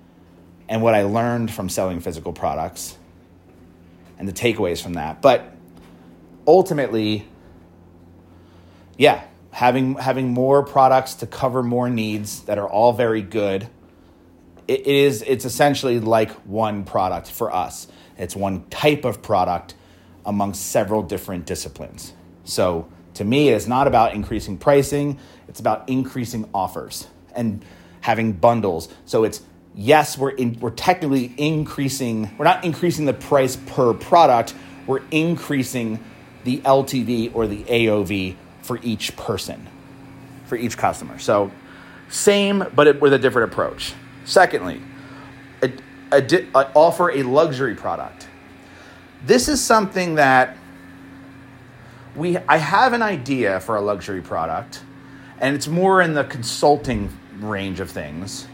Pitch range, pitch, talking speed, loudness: 90-135 Hz, 115 Hz, 135 wpm, -20 LUFS